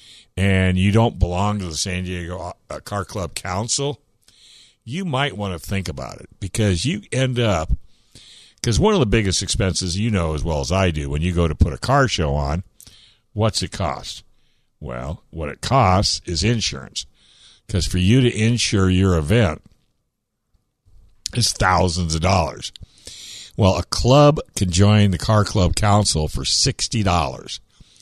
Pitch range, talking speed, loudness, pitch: 90-110 Hz, 160 wpm, -19 LUFS, 95 Hz